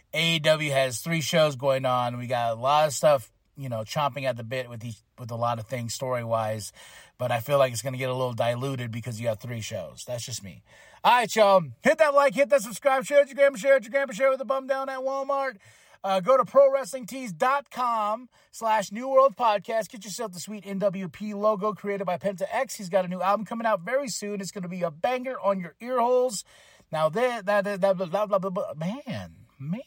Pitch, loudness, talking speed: 195 Hz, -26 LUFS, 240 wpm